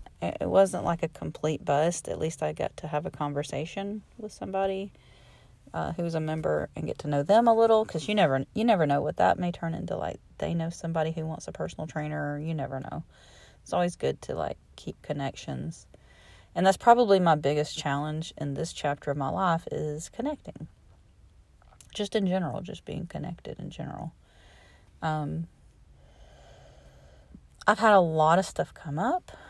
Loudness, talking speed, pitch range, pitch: -28 LUFS, 180 wpm, 150-190 Hz, 160 Hz